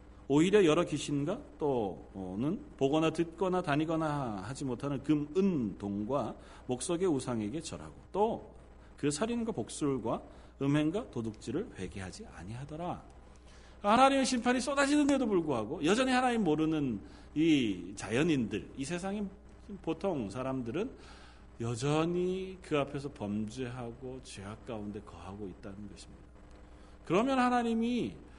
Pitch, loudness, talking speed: 145 Hz, -32 LUFS, 290 characters per minute